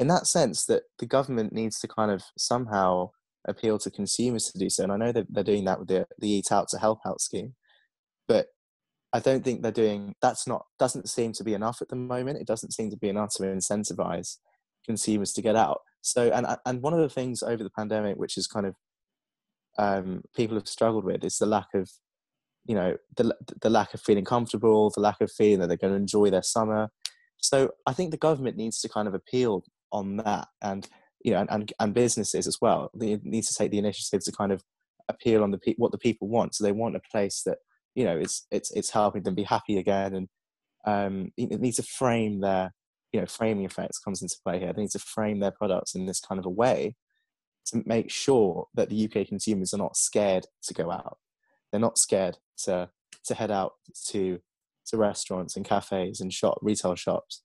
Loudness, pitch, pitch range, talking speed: -27 LUFS, 105 Hz, 100-115 Hz, 220 wpm